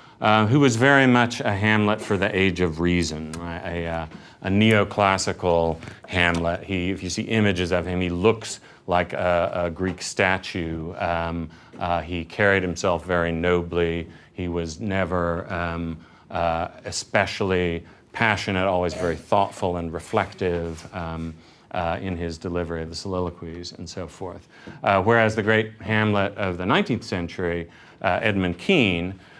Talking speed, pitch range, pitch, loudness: 150 wpm, 85-100 Hz, 90 Hz, -23 LUFS